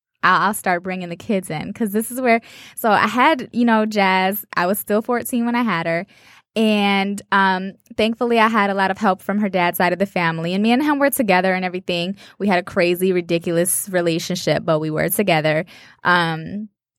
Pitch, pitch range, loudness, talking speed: 195 Hz, 180-220 Hz, -19 LUFS, 210 wpm